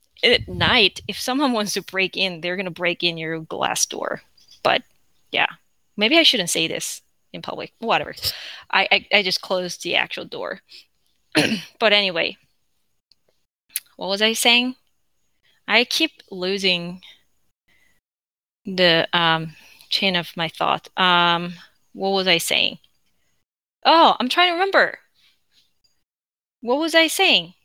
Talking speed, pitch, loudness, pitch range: 135 wpm, 195 Hz, -19 LUFS, 175-250 Hz